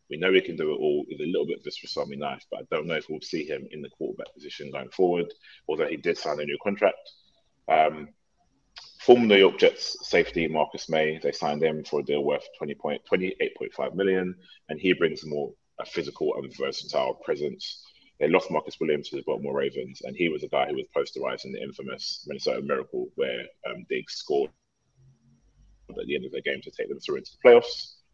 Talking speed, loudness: 220 wpm, -27 LUFS